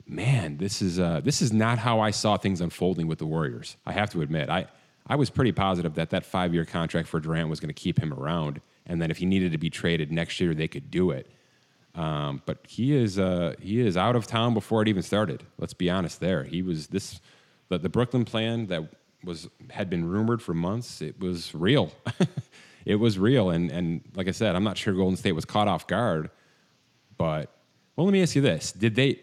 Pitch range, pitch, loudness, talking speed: 85-115 Hz, 95 Hz, -27 LUFS, 230 wpm